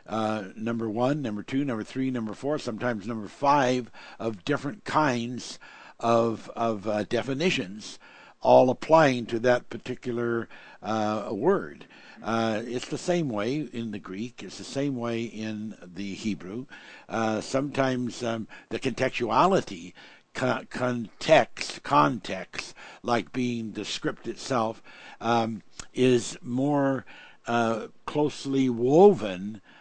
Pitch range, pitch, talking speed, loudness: 110-130 Hz, 120 Hz, 120 wpm, -27 LUFS